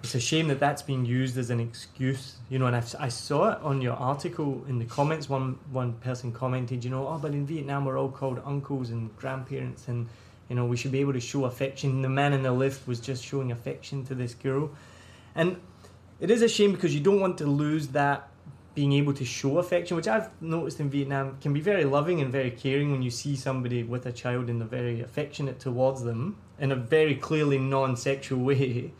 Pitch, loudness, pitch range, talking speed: 135 Hz, -28 LUFS, 125-145 Hz, 230 wpm